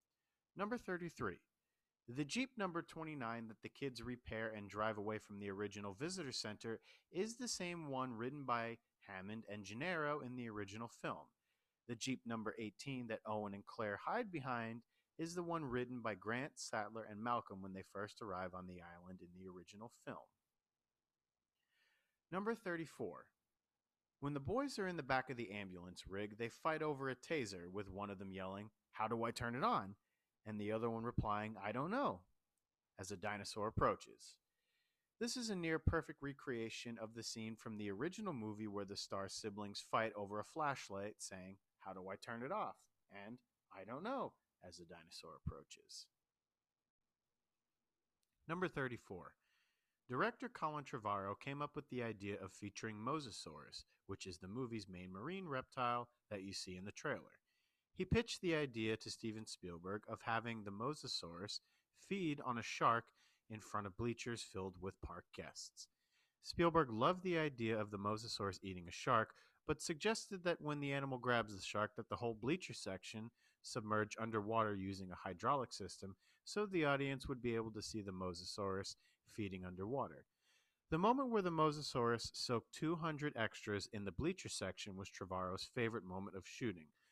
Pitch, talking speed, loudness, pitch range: 115 Hz, 170 wpm, -44 LUFS, 100-140 Hz